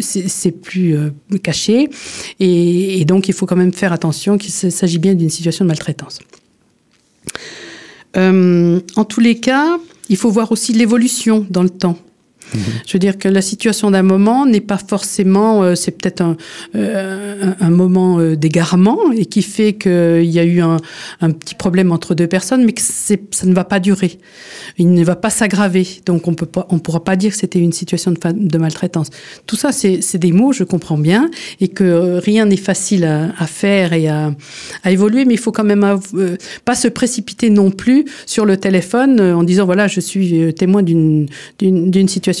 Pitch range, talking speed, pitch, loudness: 175-205 Hz, 200 wpm, 190 Hz, -14 LUFS